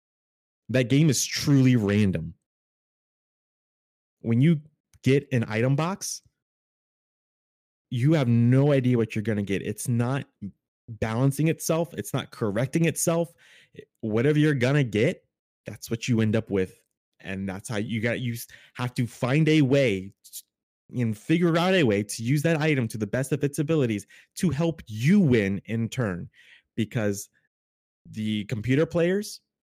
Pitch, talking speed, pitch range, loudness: 125 Hz, 150 wpm, 110-150 Hz, -25 LUFS